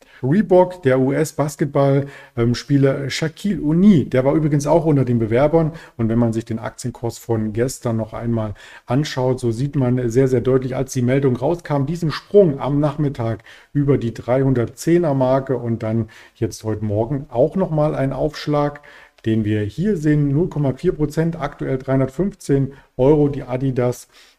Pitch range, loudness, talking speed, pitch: 120-150 Hz, -19 LUFS, 145 wpm, 135 Hz